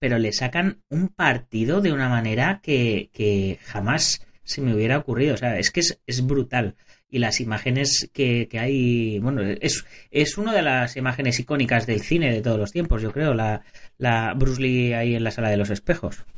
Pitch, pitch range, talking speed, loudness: 125 Hz, 110-135 Hz, 200 wpm, -23 LUFS